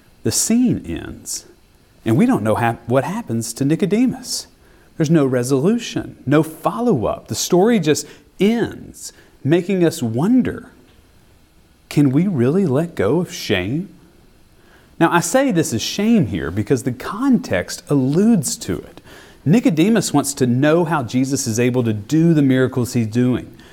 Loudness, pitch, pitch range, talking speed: -18 LUFS, 150 Hz, 125-180 Hz, 145 wpm